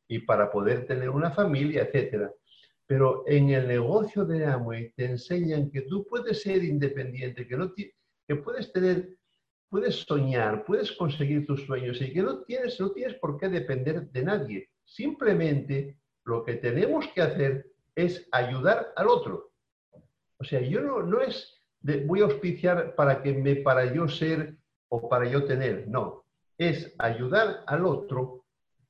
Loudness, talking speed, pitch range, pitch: -28 LUFS, 160 wpm, 130-180 Hz, 145 Hz